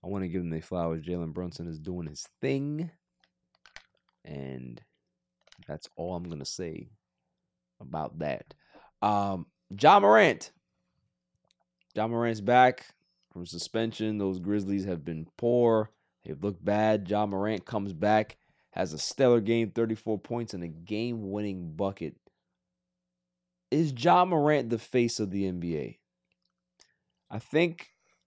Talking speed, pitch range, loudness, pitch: 135 wpm, 85-115 Hz, -28 LUFS, 100 Hz